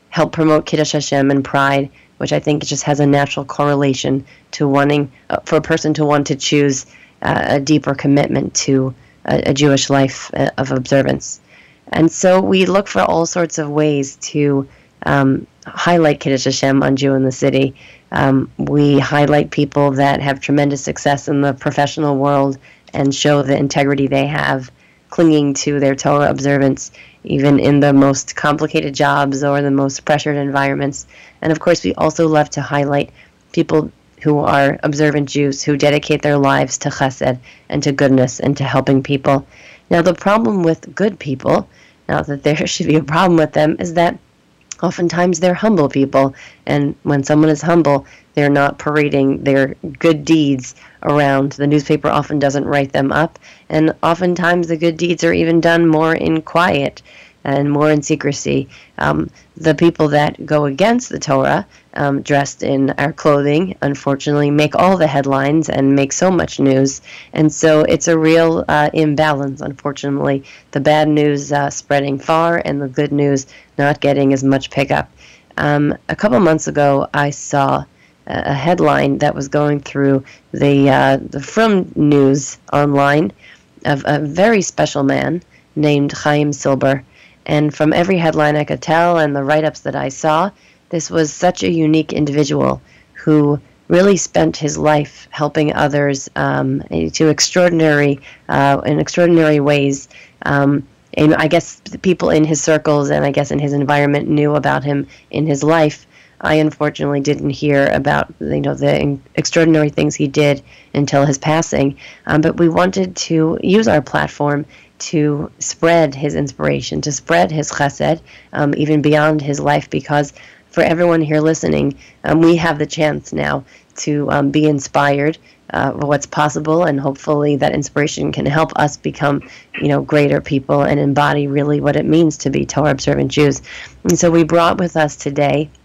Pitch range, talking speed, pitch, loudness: 140-155 Hz, 170 wpm, 145 Hz, -15 LUFS